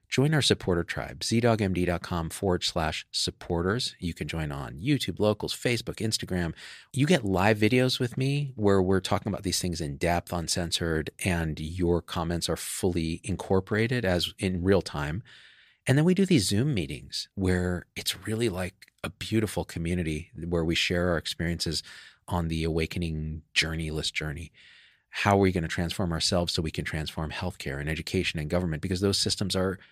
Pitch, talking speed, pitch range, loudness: 90 Hz, 170 wpm, 85-105 Hz, -28 LUFS